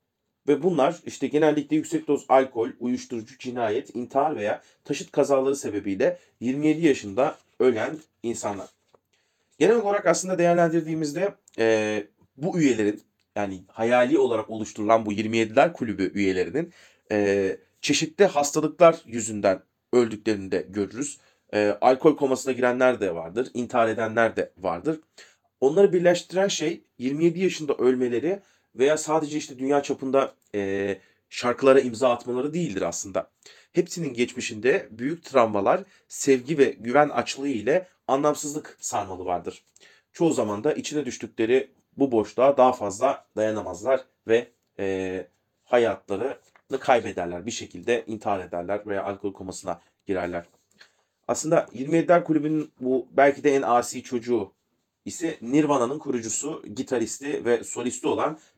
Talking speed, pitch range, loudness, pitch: 120 wpm, 110-150 Hz, -24 LUFS, 125 Hz